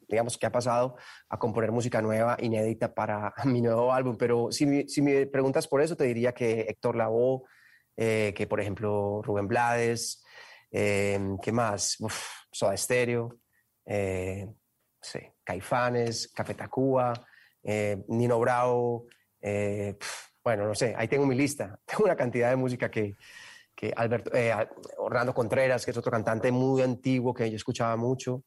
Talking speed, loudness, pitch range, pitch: 160 wpm, -28 LUFS, 105-125 Hz, 120 Hz